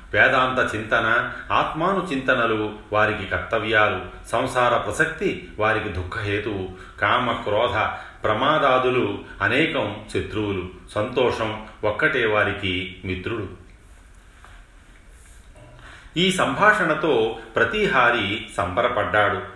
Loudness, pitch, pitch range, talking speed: -22 LUFS, 105 Hz, 90-120 Hz, 70 wpm